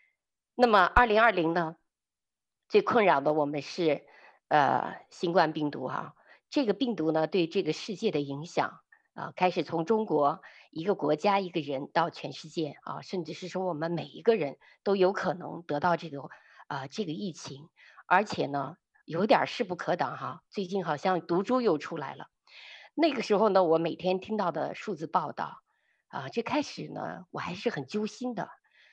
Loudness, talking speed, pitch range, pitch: -29 LUFS, 250 characters per minute, 160-215 Hz, 180 Hz